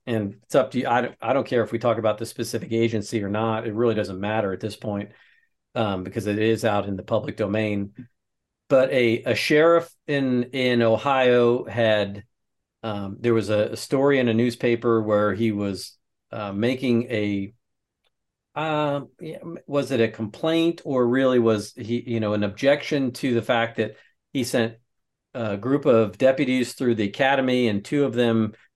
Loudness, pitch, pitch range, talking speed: -23 LUFS, 115 Hz, 105-125 Hz, 185 wpm